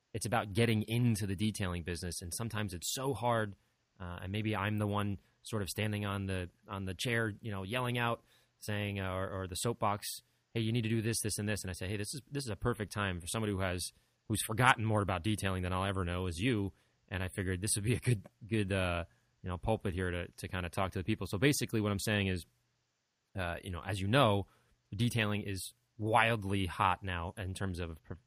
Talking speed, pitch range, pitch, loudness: 240 wpm, 95-115 Hz, 105 Hz, -35 LUFS